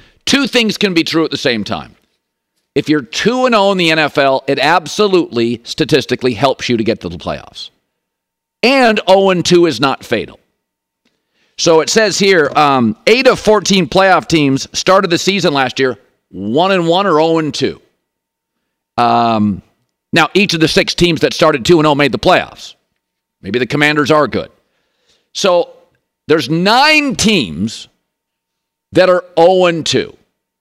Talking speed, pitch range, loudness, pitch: 160 wpm, 135-190 Hz, -12 LUFS, 160 Hz